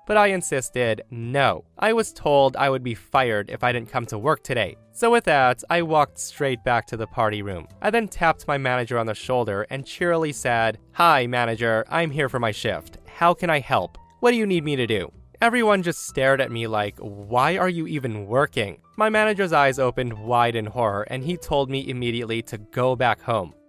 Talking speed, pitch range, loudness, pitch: 215 wpm, 115-165 Hz, -22 LUFS, 130 Hz